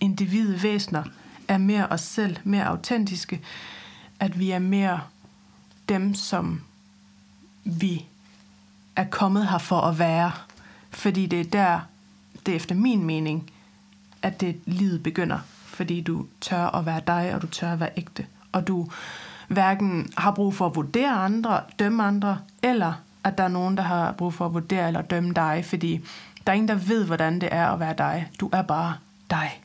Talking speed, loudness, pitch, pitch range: 175 wpm, -25 LUFS, 180 Hz, 165-195 Hz